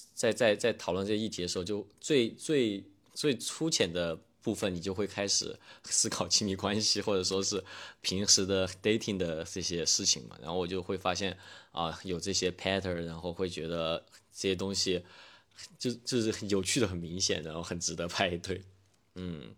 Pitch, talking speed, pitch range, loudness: 95 Hz, 295 characters per minute, 90-105 Hz, -31 LUFS